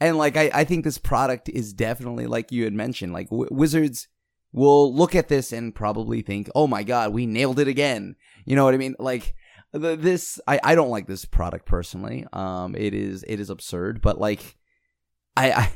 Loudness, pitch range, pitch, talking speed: -23 LUFS, 100-145 Hz, 120 Hz, 210 wpm